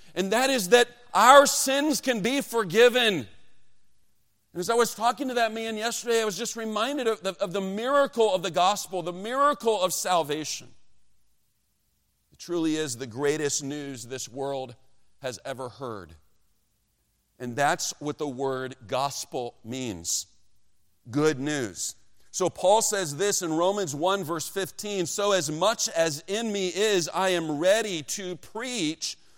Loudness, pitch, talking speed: -25 LUFS, 175 Hz, 155 wpm